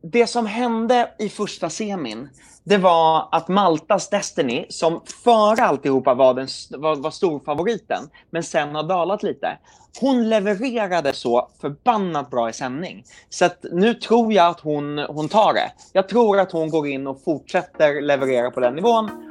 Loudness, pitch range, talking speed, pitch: -20 LUFS, 145-220 Hz, 160 wpm, 175 Hz